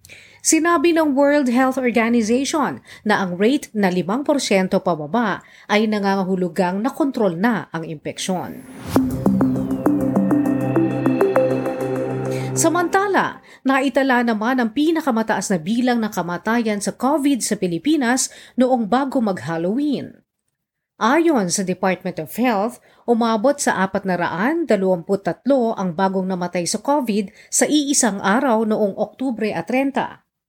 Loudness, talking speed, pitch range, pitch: -19 LUFS, 110 wpm, 185-265 Hz, 220 Hz